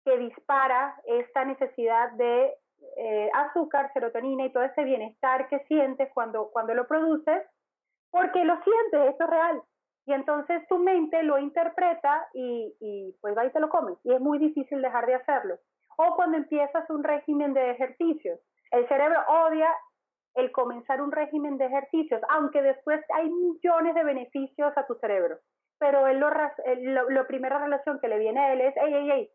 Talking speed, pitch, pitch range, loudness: 175 wpm, 285 Hz, 260-320 Hz, -26 LUFS